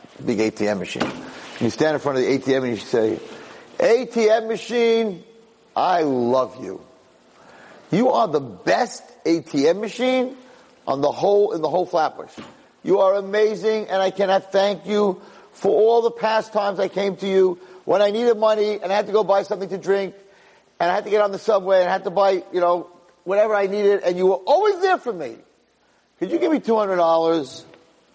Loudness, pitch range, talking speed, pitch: -20 LUFS, 175-220 Hz, 195 wpm, 195 Hz